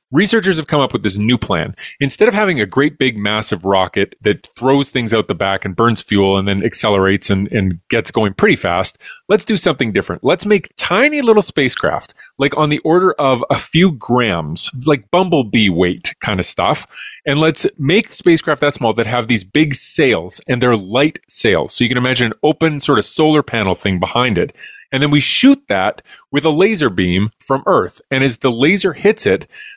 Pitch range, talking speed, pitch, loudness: 110-160 Hz, 205 wpm, 135 Hz, -14 LUFS